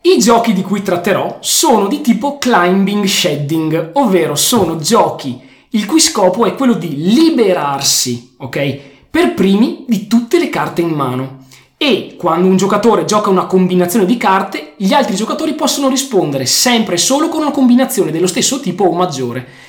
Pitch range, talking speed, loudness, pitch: 160-240 Hz, 165 wpm, -12 LUFS, 190 Hz